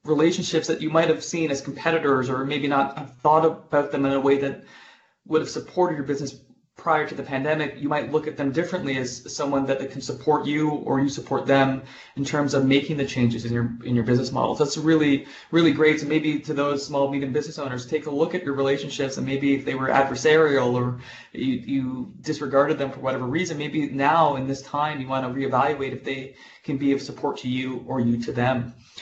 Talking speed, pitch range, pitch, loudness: 225 wpm, 135-155 Hz, 140 Hz, -24 LUFS